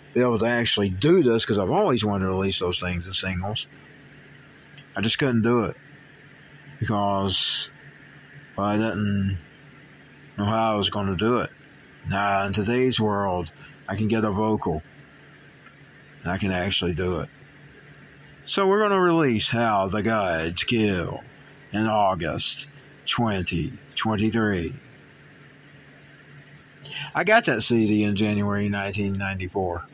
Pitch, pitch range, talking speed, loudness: 110 Hz, 100-140 Hz, 135 wpm, -24 LUFS